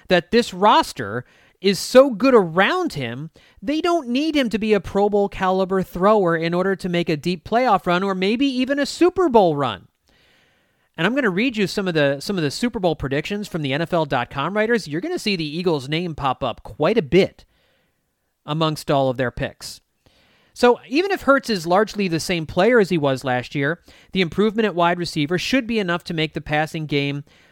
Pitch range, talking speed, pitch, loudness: 155-220 Hz, 210 wpm, 185 Hz, -20 LUFS